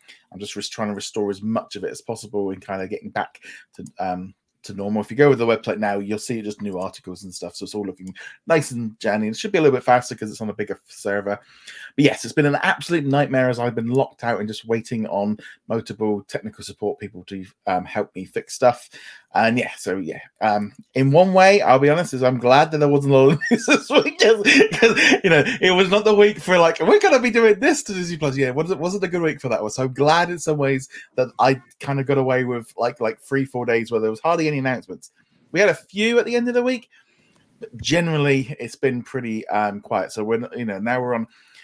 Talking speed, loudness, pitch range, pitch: 255 wpm, -20 LUFS, 110-160 Hz, 125 Hz